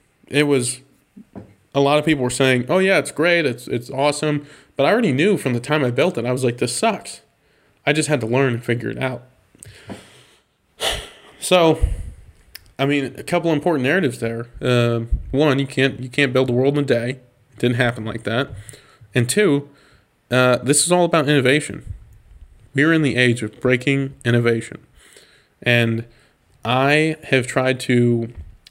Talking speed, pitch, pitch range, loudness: 175 wpm, 130 Hz, 120-145 Hz, -19 LUFS